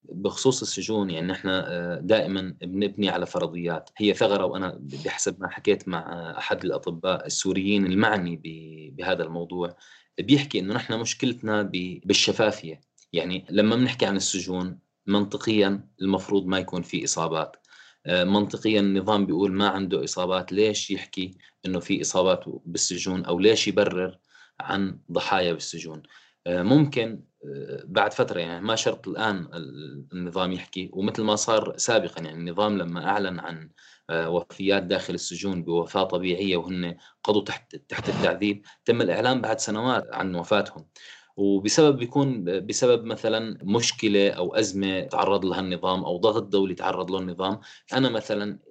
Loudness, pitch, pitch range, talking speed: -25 LUFS, 95 Hz, 90-105 Hz, 130 wpm